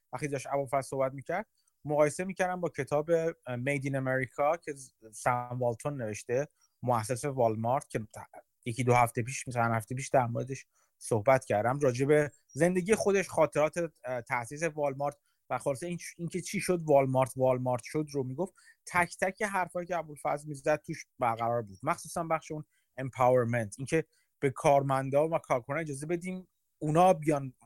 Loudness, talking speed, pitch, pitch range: -31 LUFS, 155 wpm, 140 Hz, 125-165 Hz